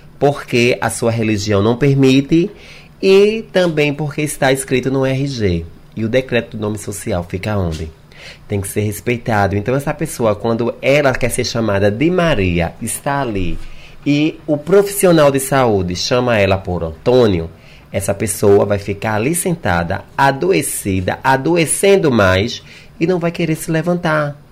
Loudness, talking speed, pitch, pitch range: -15 LUFS, 150 wpm, 125 Hz, 100-150 Hz